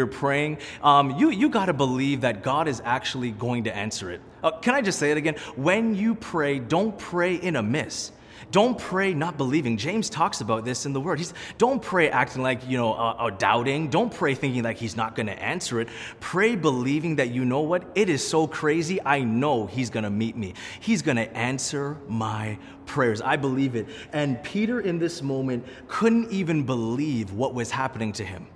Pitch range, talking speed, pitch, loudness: 120-170 Hz, 210 wpm, 140 Hz, -25 LUFS